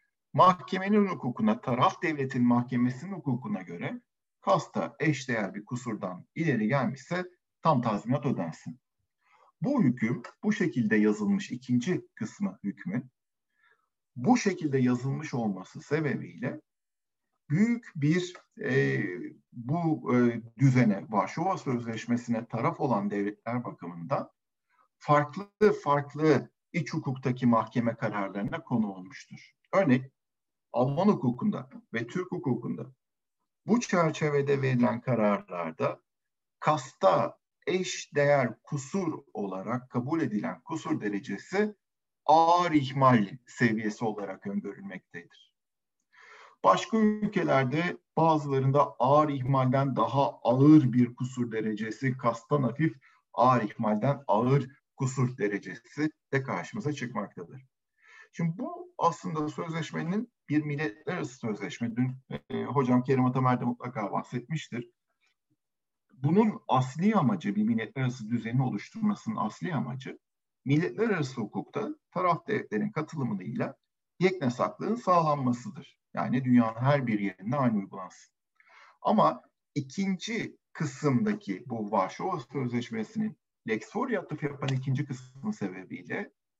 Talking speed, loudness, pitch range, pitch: 100 wpm, -29 LUFS, 120-170 Hz, 135 Hz